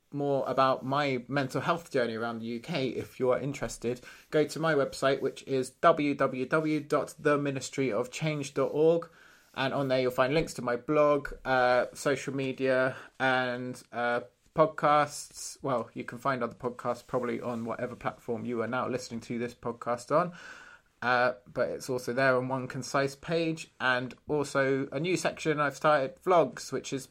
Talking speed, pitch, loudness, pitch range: 160 wpm, 135 Hz, -30 LUFS, 125-145 Hz